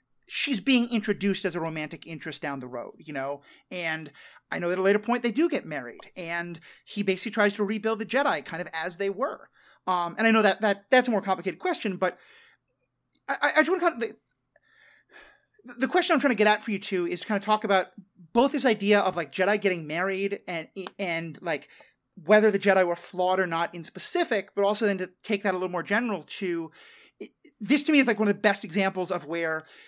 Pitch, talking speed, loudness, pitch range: 200 Hz, 235 wpm, -26 LUFS, 180-230 Hz